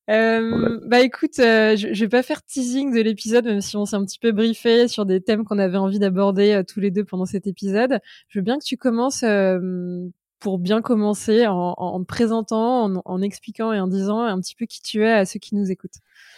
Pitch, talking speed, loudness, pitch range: 215 Hz, 240 wpm, -20 LUFS, 195-230 Hz